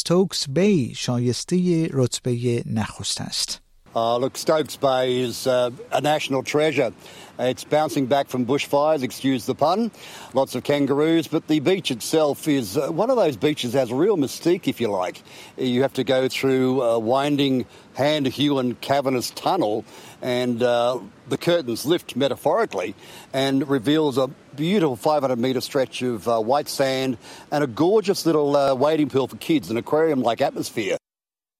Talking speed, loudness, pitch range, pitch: 160 wpm, -22 LUFS, 125-150 Hz, 135 Hz